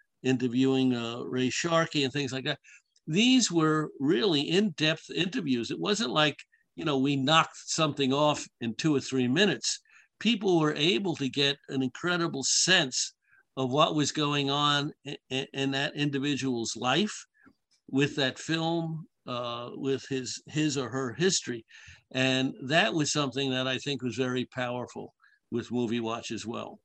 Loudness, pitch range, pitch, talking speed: -28 LUFS, 130-160 Hz, 140 Hz, 155 wpm